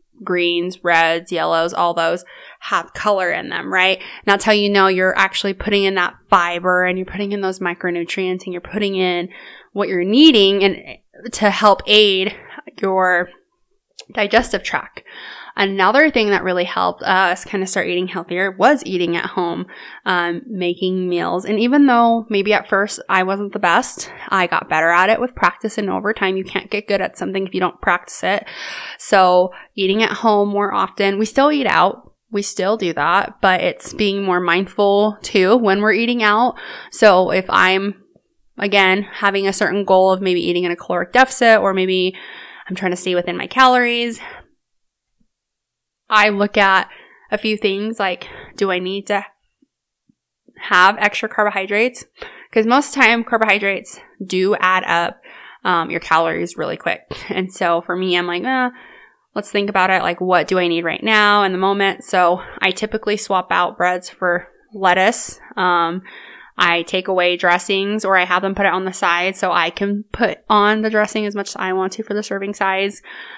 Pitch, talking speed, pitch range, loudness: 195 Hz, 185 wpm, 185-210 Hz, -16 LUFS